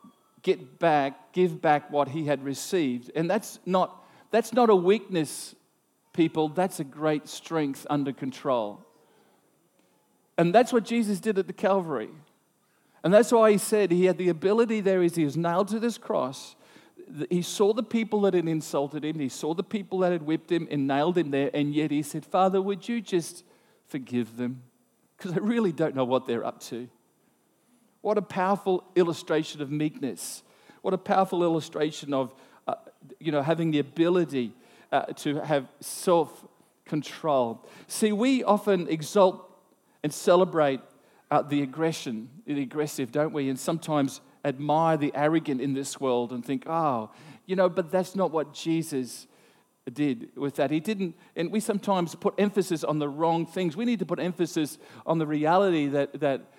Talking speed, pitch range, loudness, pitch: 170 wpm, 145-190 Hz, -27 LUFS, 165 Hz